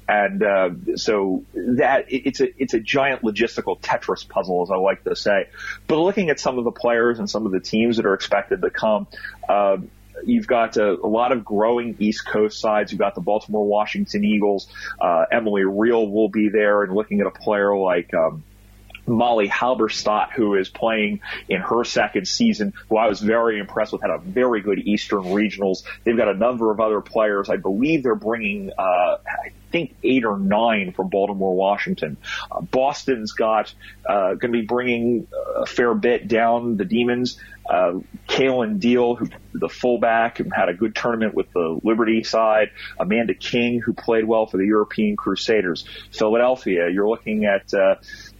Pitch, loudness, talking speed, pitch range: 110 Hz, -21 LUFS, 180 wpm, 105-120 Hz